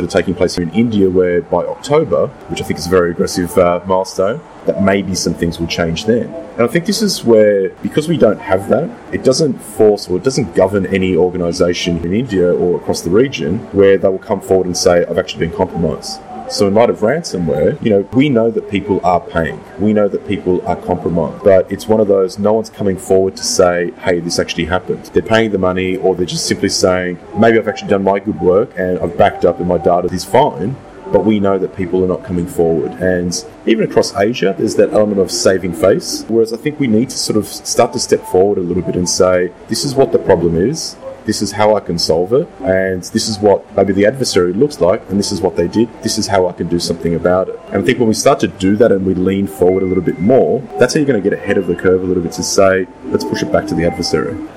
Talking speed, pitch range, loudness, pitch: 255 wpm, 90-105 Hz, -14 LUFS, 95 Hz